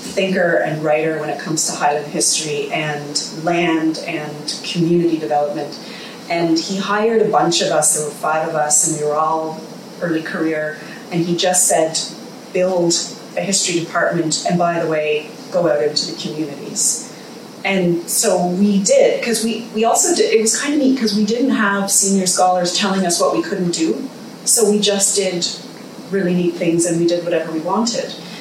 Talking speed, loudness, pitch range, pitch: 185 wpm, -17 LUFS, 160-215 Hz, 180 Hz